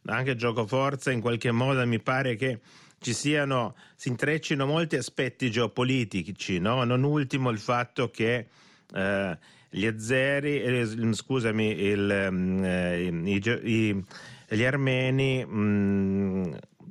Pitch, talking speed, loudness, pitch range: 125 Hz, 115 wpm, -27 LUFS, 105-135 Hz